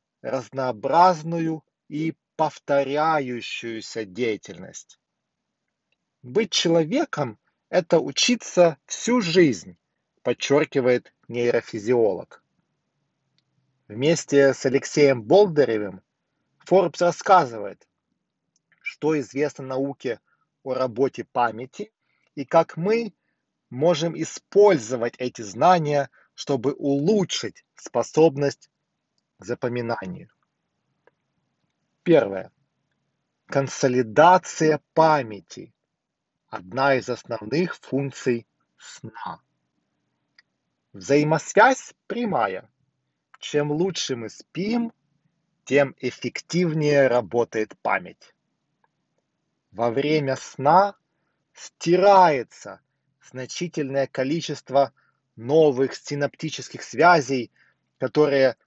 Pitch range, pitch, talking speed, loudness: 130-165 Hz, 140 Hz, 65 wpm, -22 LUFS